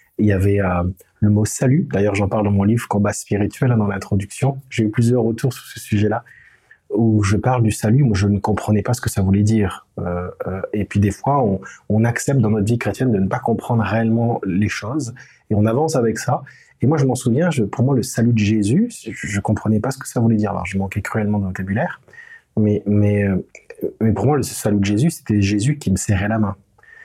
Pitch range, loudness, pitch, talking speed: 105-120 Hz, -19 LUFS, 110 Hz, 240 wpm